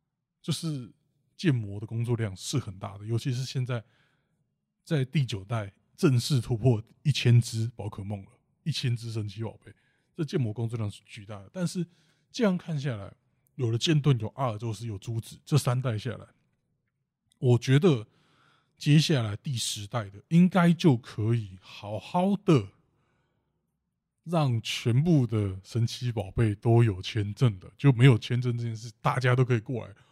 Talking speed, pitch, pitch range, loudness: 235 characters per minute, 125 Hz, 115-150 Hz, -28 LUFS